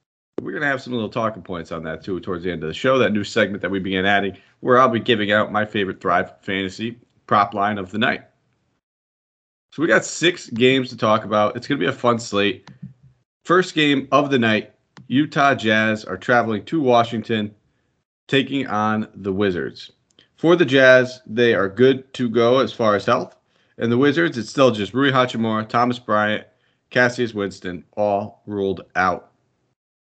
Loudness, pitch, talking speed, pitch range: -19 LUFS, 115 Hz, 190 wpm, 105-130 Hz